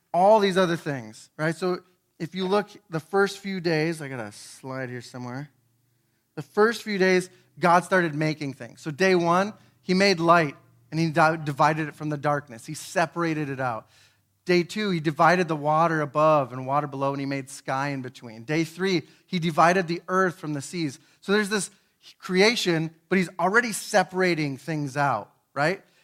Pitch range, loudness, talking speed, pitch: 140-185 Hz, -24 LUFS, 185 wpm, 160 Hz